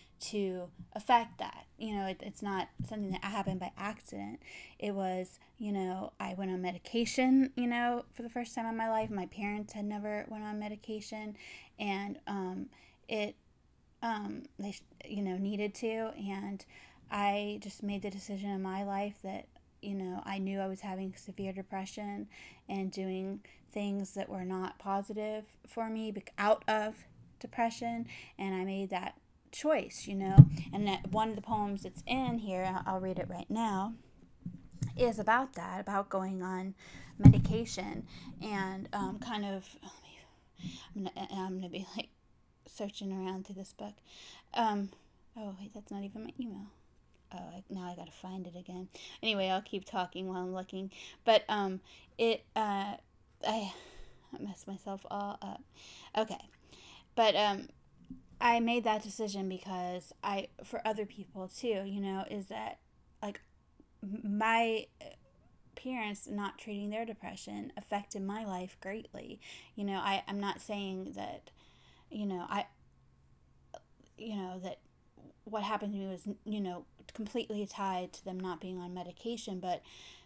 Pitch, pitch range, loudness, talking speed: 200 Hz, 190-215 Hz, -35 LUFS, 155 wpm